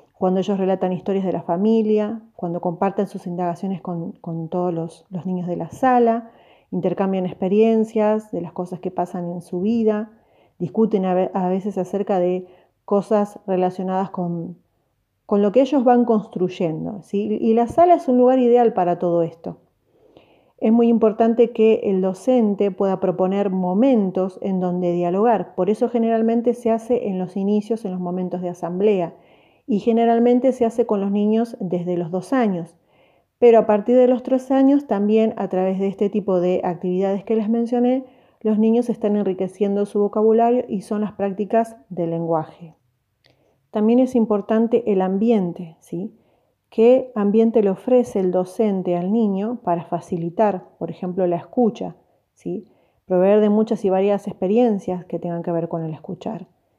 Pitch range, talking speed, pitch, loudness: 180-225 Hz, 165 wpm, 200 Hz, -20 LUFS